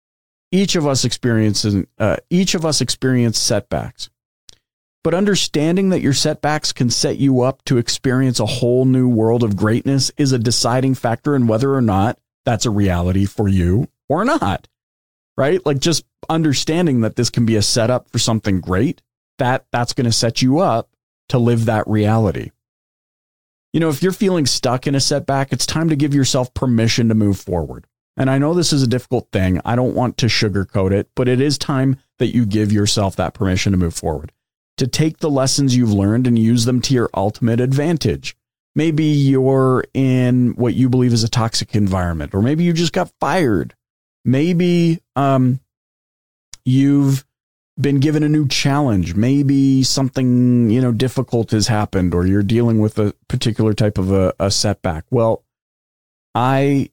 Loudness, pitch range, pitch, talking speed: -17 LUFS, 110-140 Hz, 125 Hz, 175 wpm